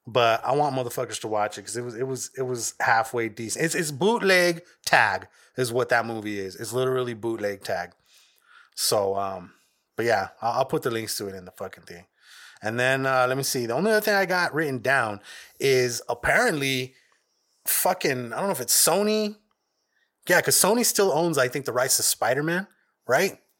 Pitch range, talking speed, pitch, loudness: 115-160 Hz, 205 wpm, 130 Hz, -24 LUFS